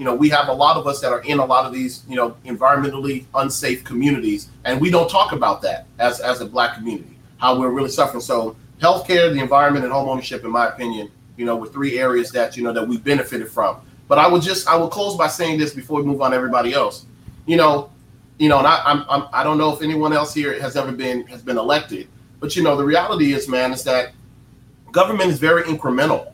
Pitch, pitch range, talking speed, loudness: 140 Hz, 125-155 Hz, 245 wpm, -18 LUFS